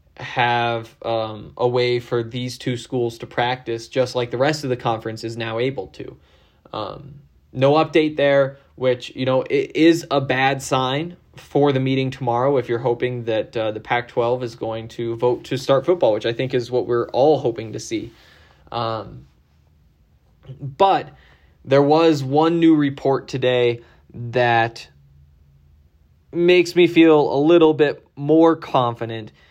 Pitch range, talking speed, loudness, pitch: 115-140 Hz, 160 wpm, -19 LUFS, 125 Hz